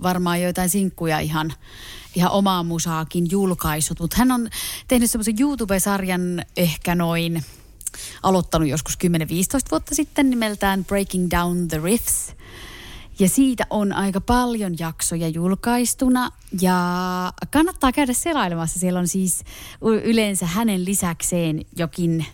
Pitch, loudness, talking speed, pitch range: 180 Hz, -21 LUFS, 120 wpm, 165-220 Hz